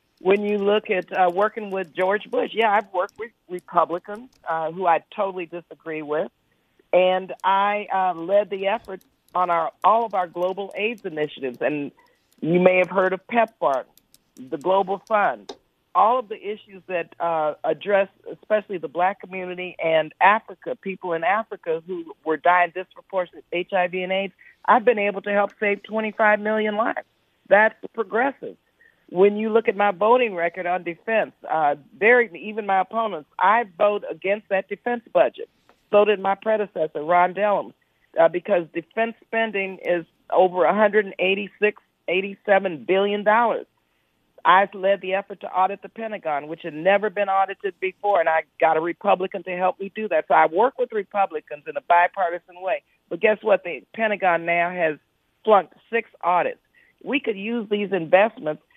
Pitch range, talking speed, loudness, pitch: 180-215 Hz, 165 wpm, -22 LUFS, 195 Hz